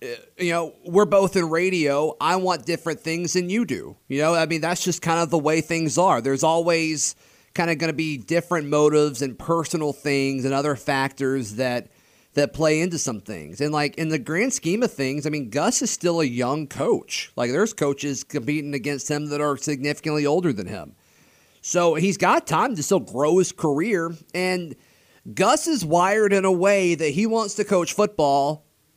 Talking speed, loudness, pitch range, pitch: 200 wpm, -22 LUFS, 145-180 Hz, 160 Hz